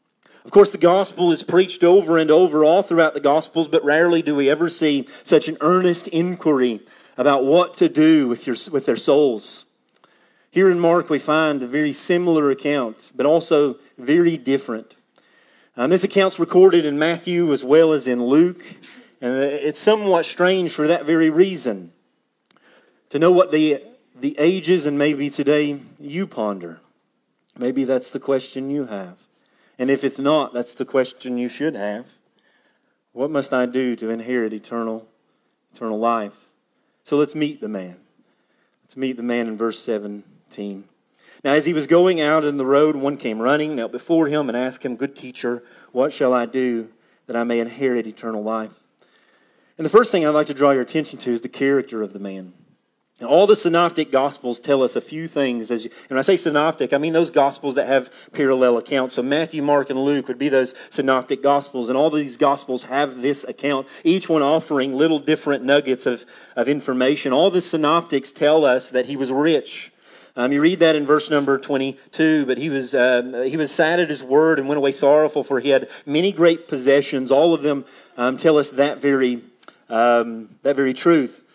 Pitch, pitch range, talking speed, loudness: 140 Hz, 125-160 Hz, 190 wpm, -19 LUFS